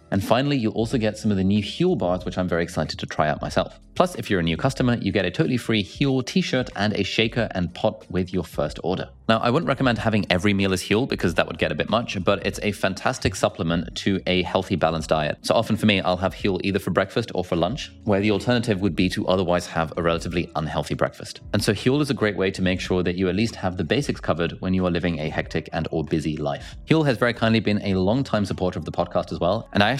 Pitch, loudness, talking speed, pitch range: 100 Hz, -23 LUFS, 270 wpm, 90-115 Hz